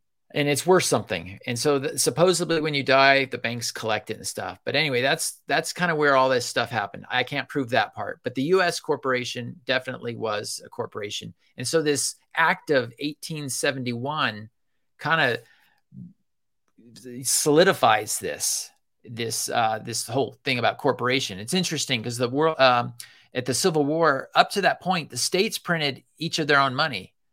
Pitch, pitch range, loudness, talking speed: 135 Hz, 120-155 Hz, -24 LUFS, 175 wpm